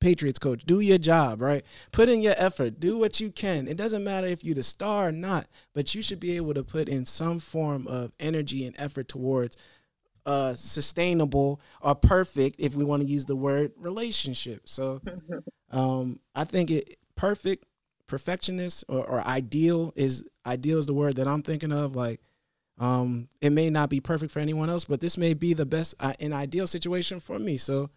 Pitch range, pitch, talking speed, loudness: 135-175 Hz, 150 Hz, 200 wpm, -27 LUFS